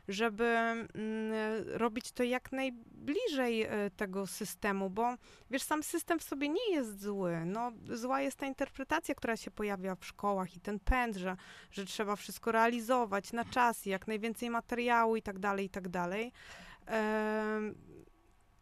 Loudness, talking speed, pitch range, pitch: -35 LUFS, 155 wpm, 205-250 Hz, 230 Hz